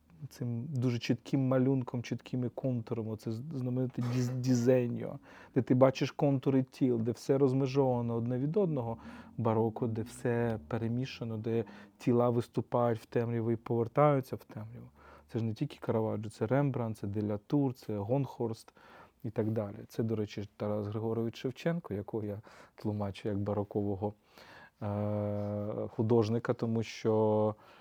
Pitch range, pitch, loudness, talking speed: 110-130 Hz, 115 Hz, -33 LUFS, 135 wpm